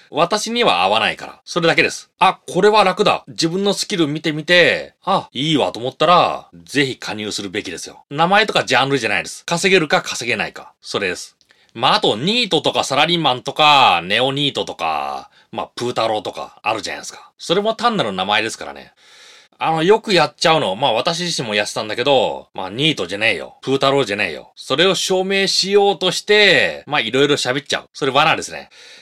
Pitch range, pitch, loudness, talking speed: 140-195 Hz, 170 Hz, -16 LUFS, 420 characters per minute